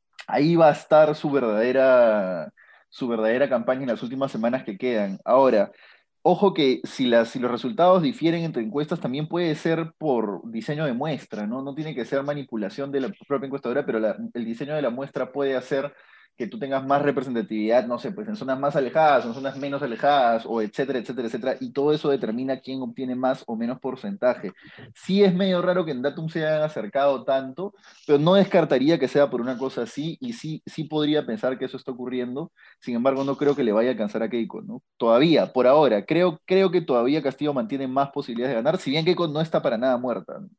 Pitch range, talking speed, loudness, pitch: 125-155 Hz, 215 wpm, -23 LUFS, 140 Hz